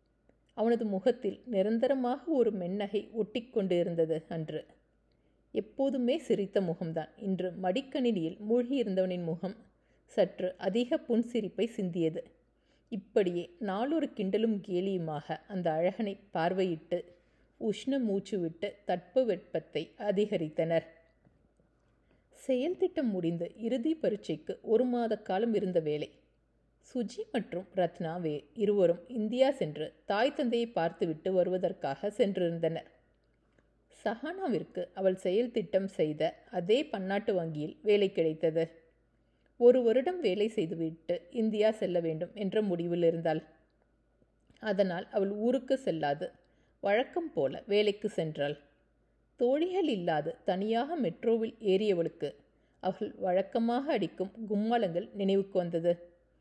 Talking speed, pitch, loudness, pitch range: 95 wpm, 195 Hz, -32 LUFS, 170-230 Hz